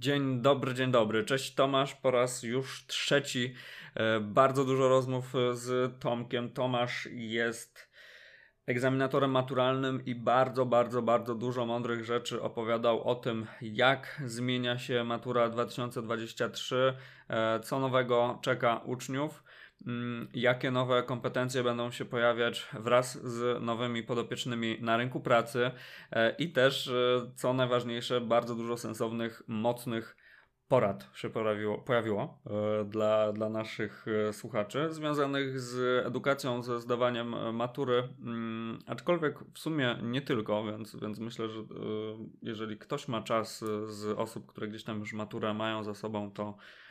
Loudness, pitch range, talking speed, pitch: -32 LUFS, 115-130 Hz, 125 wpm, 120 Hz